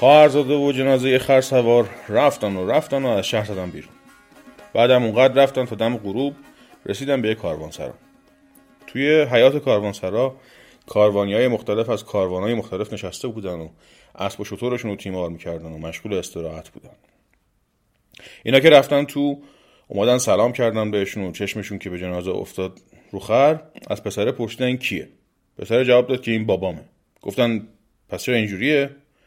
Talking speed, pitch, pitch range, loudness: 155 wpm, 120 Hz, 100-135 Hz, -20 LUFS